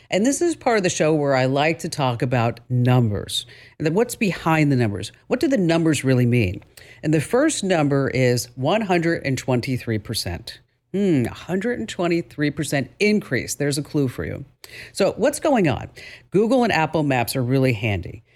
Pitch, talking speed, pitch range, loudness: 145 Hz, 165 wpm, 125-180 Hz, -21 LUFS